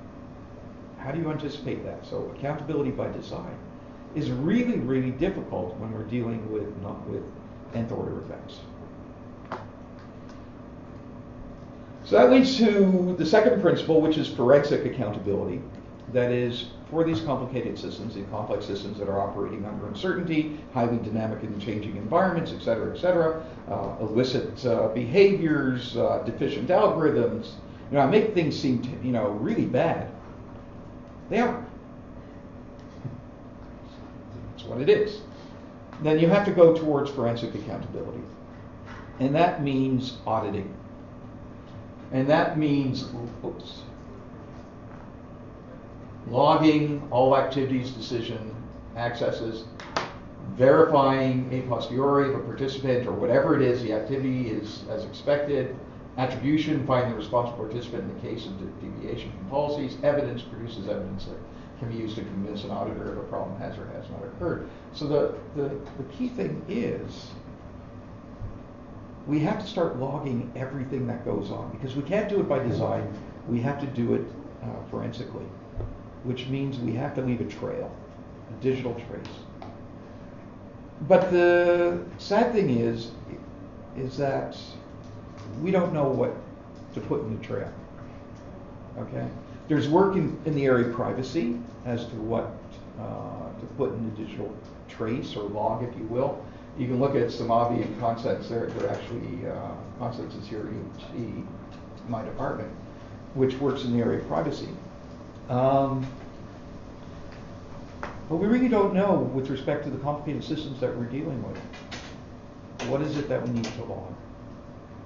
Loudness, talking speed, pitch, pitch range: -26 LUFS, 145 wpm, 120 Hz, 115-140 Hz